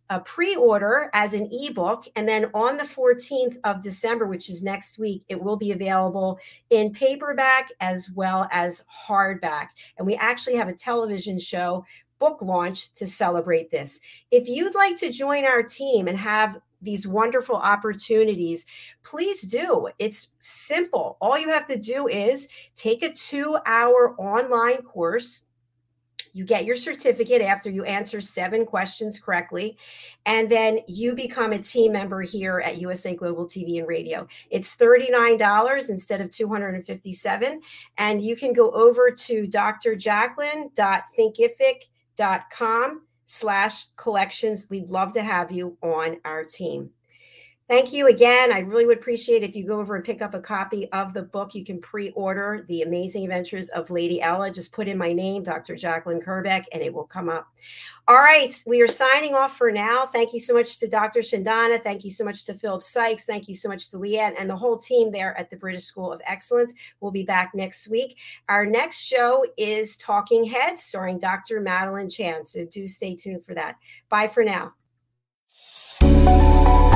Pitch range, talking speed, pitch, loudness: 185-240 Hz, 170 wpm, 215 Hz, -22 LUFS